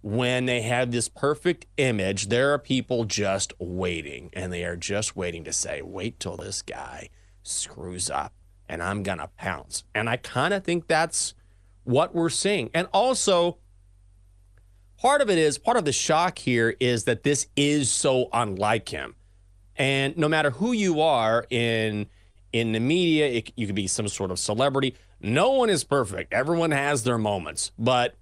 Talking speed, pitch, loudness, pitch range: 175 wpm, 115 Hz, -25 LUFS, 95-140 Hz